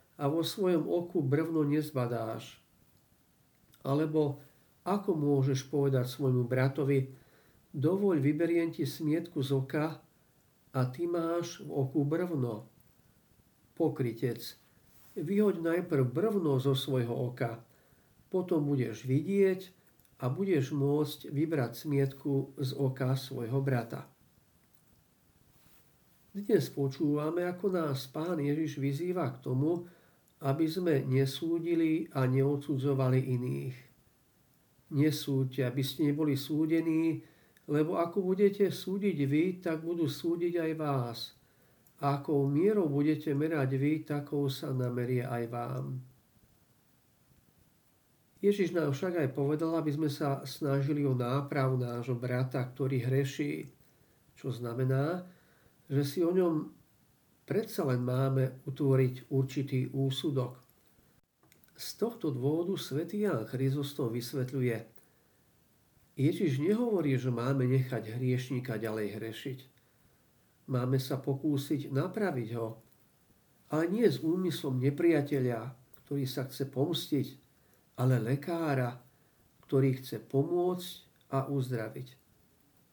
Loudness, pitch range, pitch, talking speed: -32 LUFS, 130-160 Hz, 140 Hz, 105 wpm